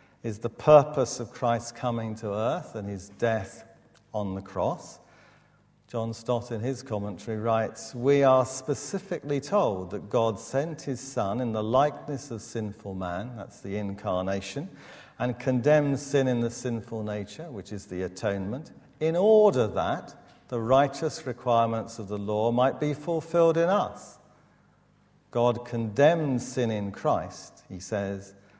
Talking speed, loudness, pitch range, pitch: 145 wpm, -27 LUFS, 105-135 Hz, 120 Hz